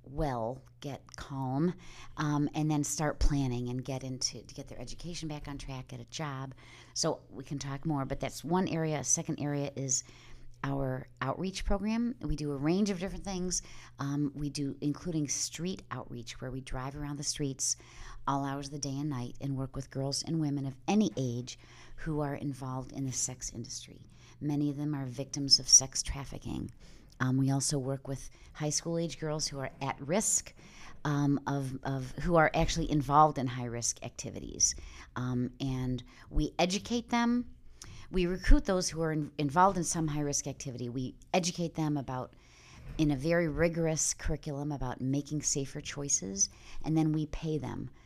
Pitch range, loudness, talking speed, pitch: 130-155 Hz, -32 LUFS, 180 wpm, 140 Hz